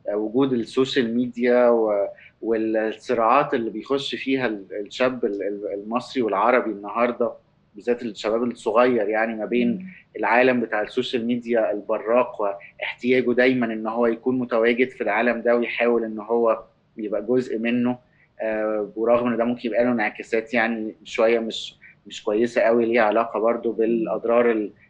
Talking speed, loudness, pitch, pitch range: 130 wpm, -22 LUFS, 115 Hz, 110-125 Hz